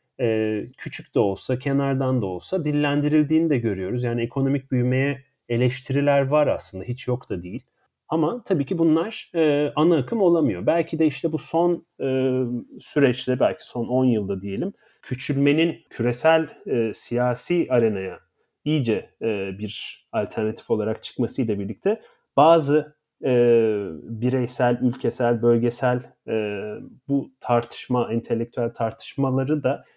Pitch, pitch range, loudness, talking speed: 130 Hz, 120-150 Hz, -23 LUFS, 125 wpm